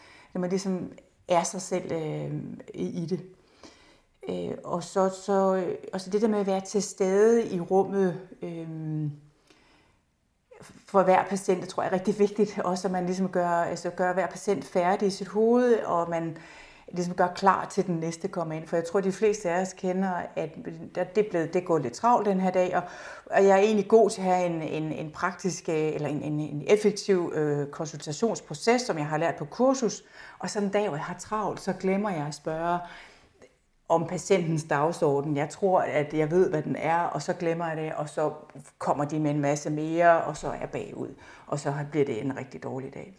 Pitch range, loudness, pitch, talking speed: 160-195 Hz, -27 LUFS, 180 Hz, 210 wpm